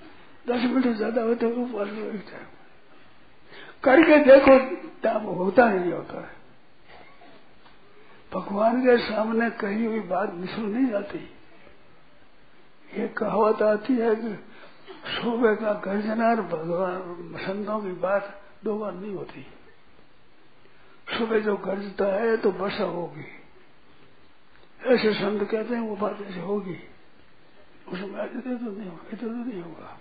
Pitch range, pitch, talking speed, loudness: 195-230 Hz, 215 Hz, 120 wpm, -24 LUFS